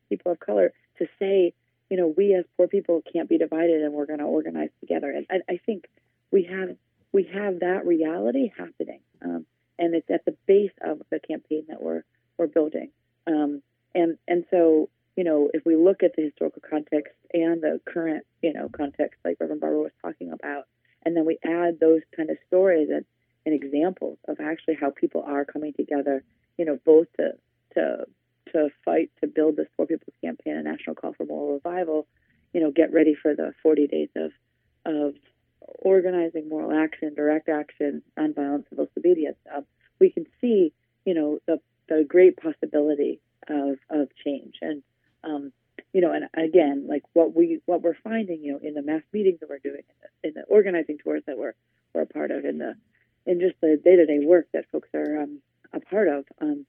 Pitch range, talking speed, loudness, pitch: 145-175 Hz, 195 wpm, -25 LUFS, 155 Hz